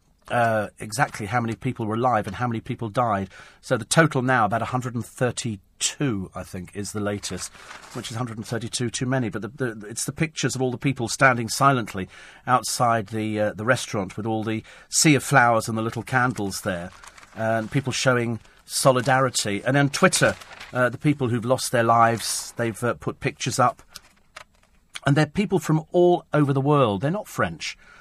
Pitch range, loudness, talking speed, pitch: 110-135 Hz, -23 LUFS, 210 wpm, 120 Hz